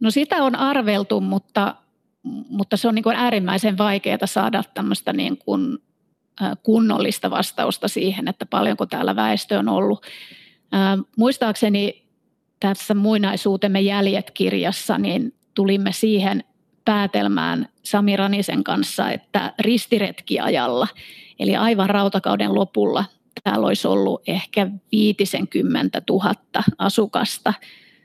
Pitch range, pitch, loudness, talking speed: 195-230 Hz, 210 Hz, -20 LUFS, 105 wpm